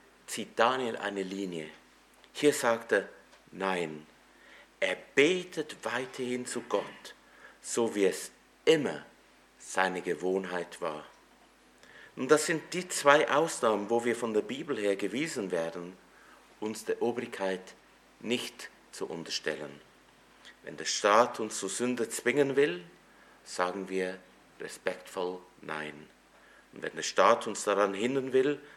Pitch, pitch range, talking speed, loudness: 100 Hz, 90-125 Hz, 125 wpm, -31 LUFS